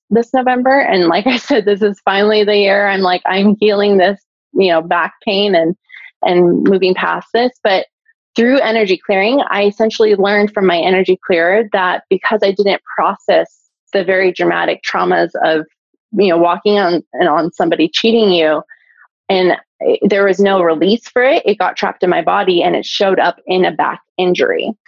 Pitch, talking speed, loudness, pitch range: 205 Hz, 185 wpm, -13 LUFS, 185-230 Hz